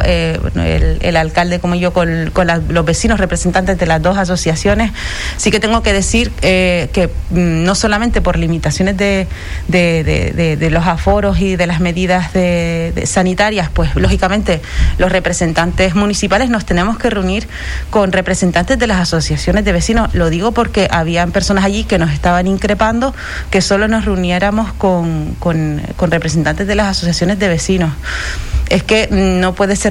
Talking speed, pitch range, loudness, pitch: 175 wpm, 170-200 Hz, -14 LUFS, 185 Hz